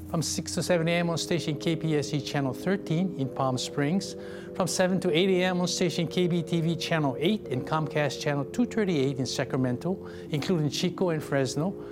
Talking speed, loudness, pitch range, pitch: 165 wpm, -28 LUFS, 145-180 Hz, 165 Hz